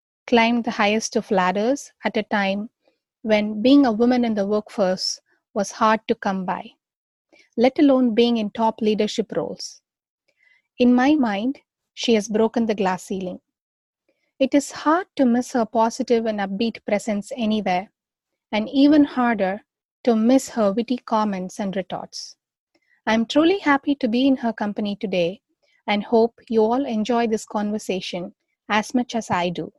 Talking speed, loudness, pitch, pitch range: 160 wpm, -21 LUFS, 225 Hz, 210-250 Hz